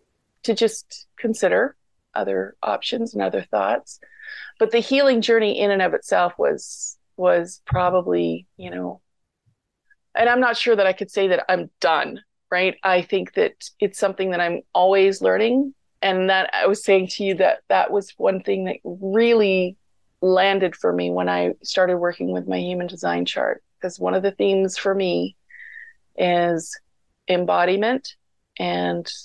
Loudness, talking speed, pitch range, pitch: -21 LUFS, 160 wpm, 175-230 Hz, 190 Hz